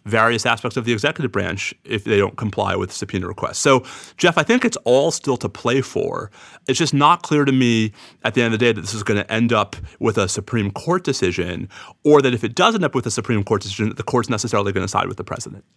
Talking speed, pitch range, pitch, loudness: 265 wpm, 105-135 Hz, 115 Hz, -19 LUFS